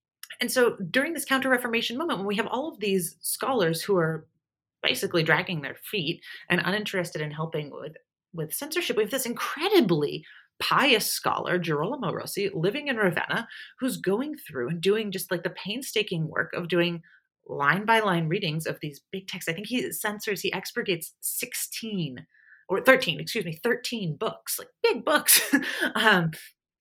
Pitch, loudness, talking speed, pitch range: 195 Hz, -26 LUFS, 170 wpm, 170-245 Hz